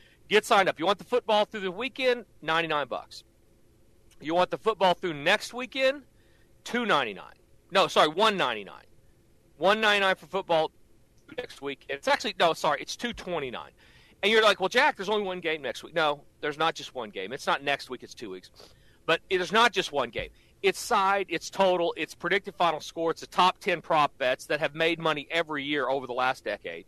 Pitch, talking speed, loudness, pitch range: 175 Hz, 215 wpm, -27 LUFS, 150-205 Hz